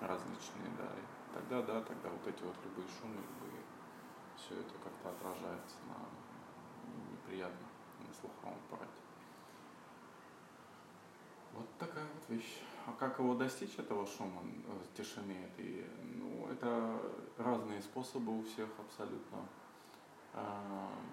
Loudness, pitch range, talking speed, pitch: -46 LUFS, 105-130 Hz, 120 wpm, 115 Hz